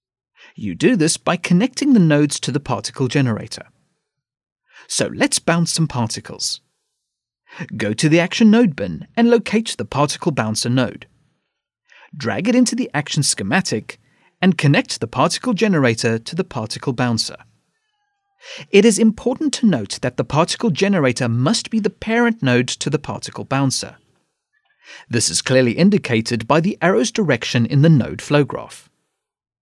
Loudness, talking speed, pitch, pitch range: -18 LUFS, 150 wpm, 150 Hz, 125-210 Hz